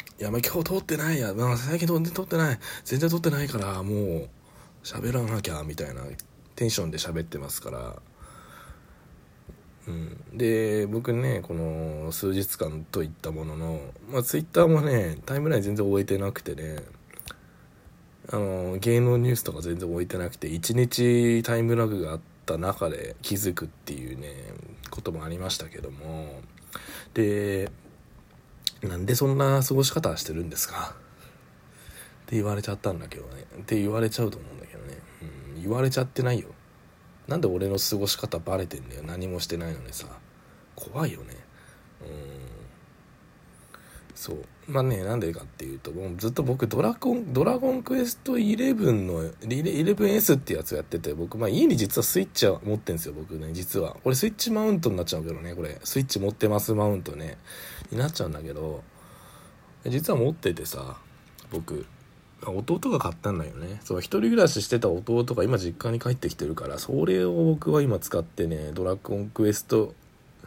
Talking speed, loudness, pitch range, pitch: 345 characters per minute, -27 LUFS, 85-125 Hz, 105 Hz